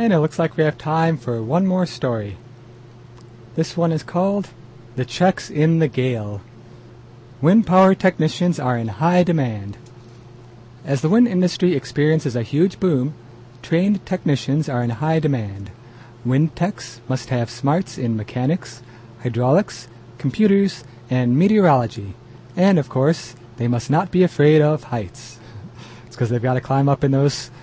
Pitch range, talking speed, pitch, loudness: 120-165 Hz, 155 wpm, 130 Hz, -20 LUFS